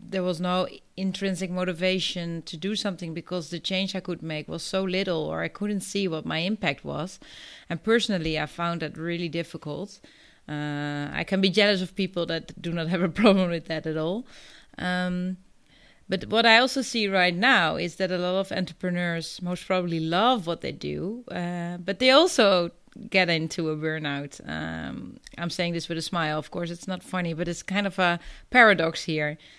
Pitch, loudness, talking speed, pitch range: 180 Hz, -26 LUFS, 195 wpm, 165-190 Hz